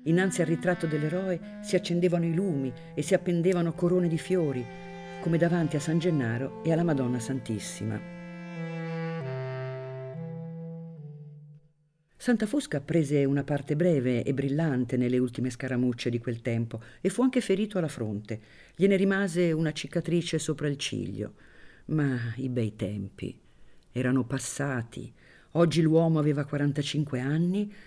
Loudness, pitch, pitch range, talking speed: -29 LUFS, 155 Hz, 130-170 Hz, 130 wpm